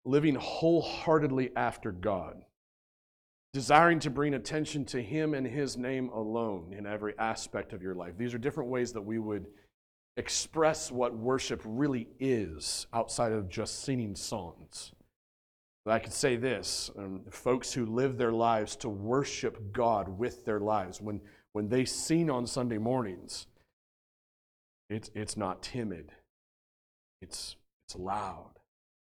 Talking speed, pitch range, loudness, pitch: 140 wpm, 105-130 Hz, -32 LUFS, 115 Hz